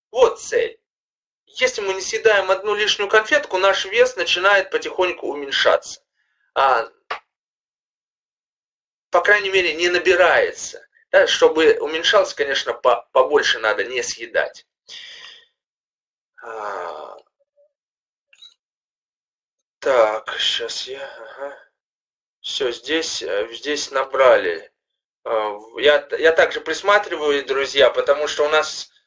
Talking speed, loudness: 95 wpm, -18 LUFS